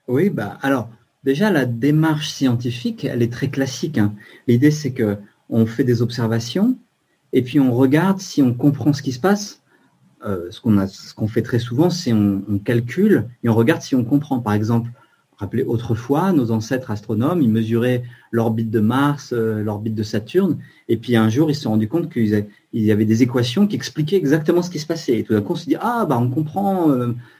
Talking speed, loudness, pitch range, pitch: 220 wpm, -19 LUFS, 115-150 Hz, 125 Hz